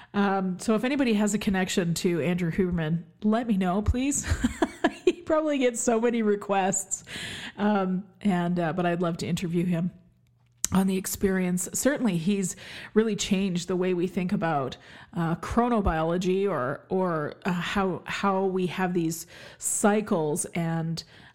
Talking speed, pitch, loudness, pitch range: 150 wpm, 190 Hz, -27 LUFS, 175-210 Hz